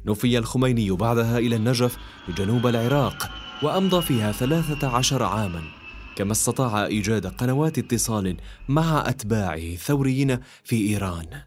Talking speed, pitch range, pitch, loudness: 115 wpm, 105-130 Hz, 115 Hz, -23 LUFS